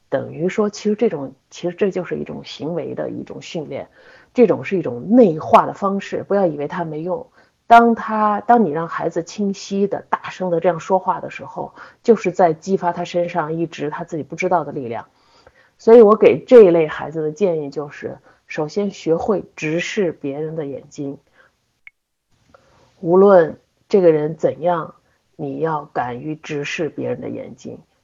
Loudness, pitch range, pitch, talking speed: -18 LUFS, 155-200 Hz, 175 Hz, 255 characters per minute